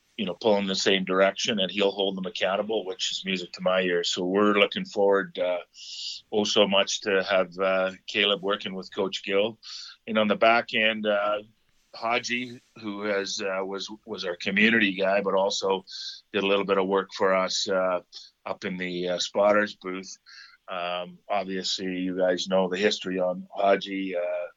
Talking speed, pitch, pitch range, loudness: 185 wpm, 95 Hz, 95-105 Hz, -25 LUFS